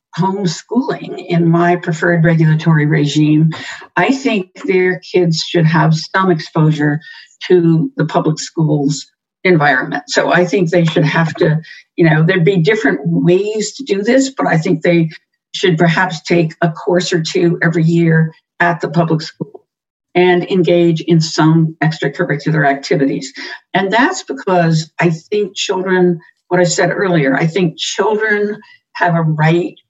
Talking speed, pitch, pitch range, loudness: 150 wpm, 170 Hz, 160-185 Hz, -14 LUFS